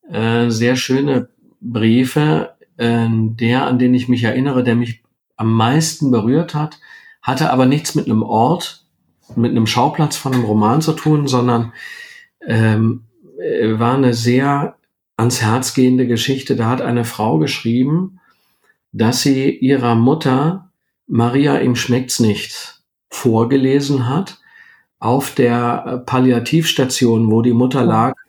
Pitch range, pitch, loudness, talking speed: 115-140 Hz, 125 Hz, -16 LUFS, 125 wpm